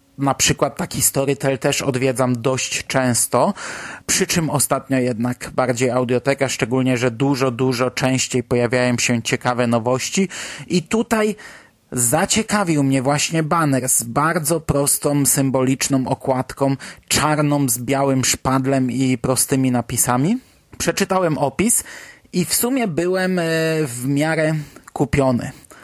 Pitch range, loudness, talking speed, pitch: 130-155 Hz, -18 LUFS, 115 wpm, 135 Hz